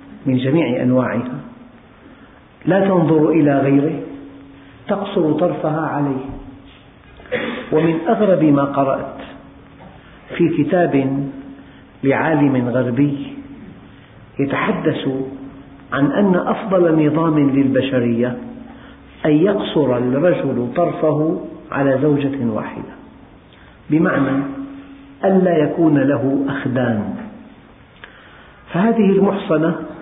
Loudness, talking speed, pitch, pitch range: -17 LUFS, 75 wpm, 145 Hz, 135-170 Hz